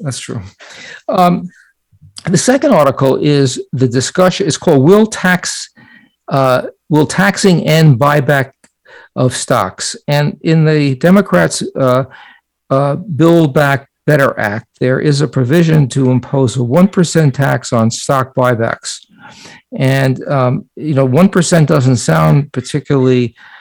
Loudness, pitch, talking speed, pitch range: -12 LUFS, 140 Hz, 130 wpm, 130-165 Hz